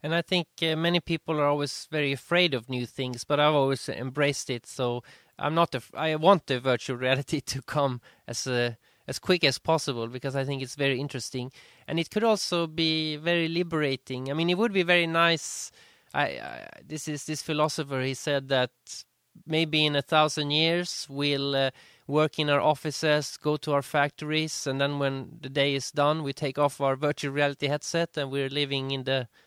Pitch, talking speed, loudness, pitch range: 145 Hz, 200 wpm, -27 LUFS, 135-155 Hz